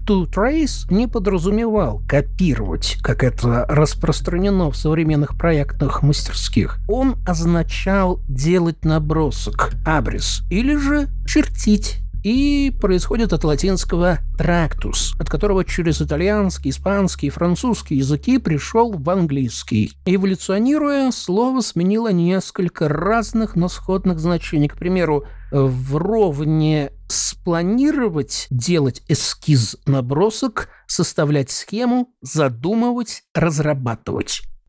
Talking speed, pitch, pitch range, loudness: 95 wpm, 170 Hz, 145-205 Hz, -19 LUFS